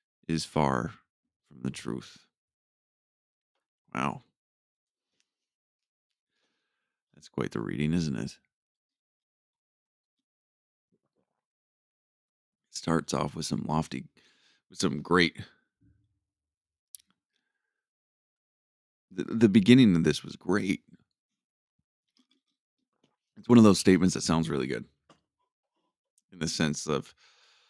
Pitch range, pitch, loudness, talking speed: 75-105 Hz, 85 Hz, -27 LUFS, 90 wpm